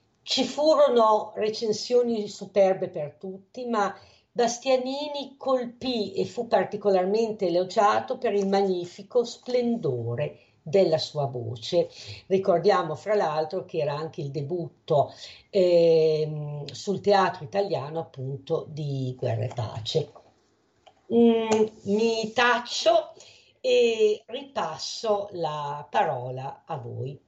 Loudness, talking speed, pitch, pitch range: -26 LUFS, 100 wpm, 195 Hz, 155-230 Hz